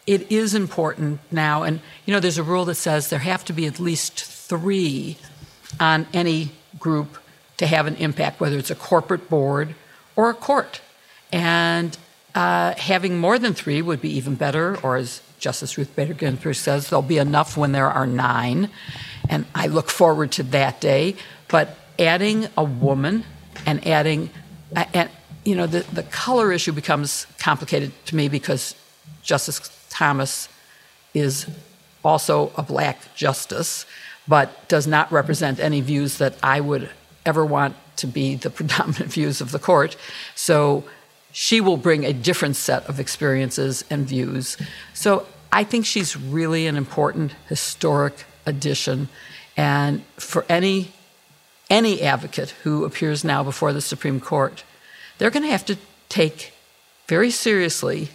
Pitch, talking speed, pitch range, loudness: 155 Hz, 155 wpm, 145-175 Hz, -21 LUFS